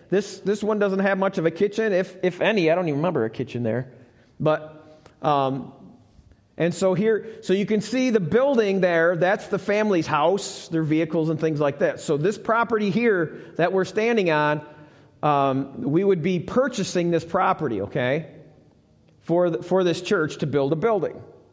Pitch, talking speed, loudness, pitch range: 180 Hz, 185 wpm, -23 LUFS, 150-200 Hz